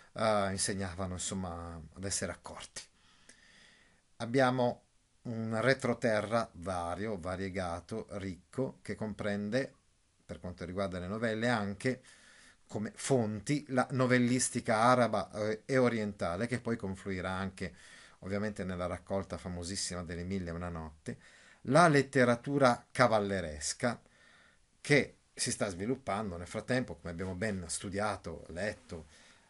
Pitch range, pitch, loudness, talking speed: 90-120 Hz, 100 Hz, -33 LUFS, 110 wpm